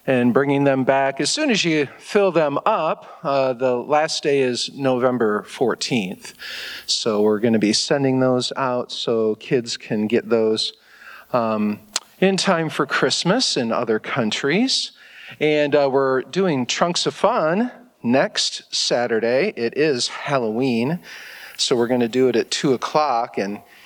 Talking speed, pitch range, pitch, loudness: 155 wpm, 120-155 Hz, 135 Hz, -20 LUFS